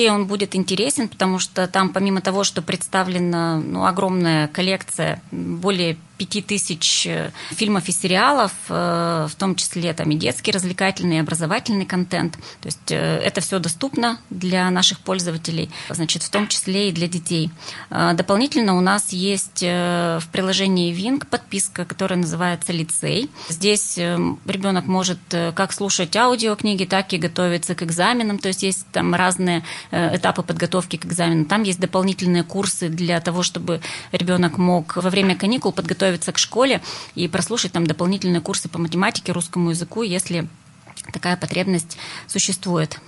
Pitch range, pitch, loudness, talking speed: 170-195 Hz, 180 Hz, -20 LUFS, 140 wpm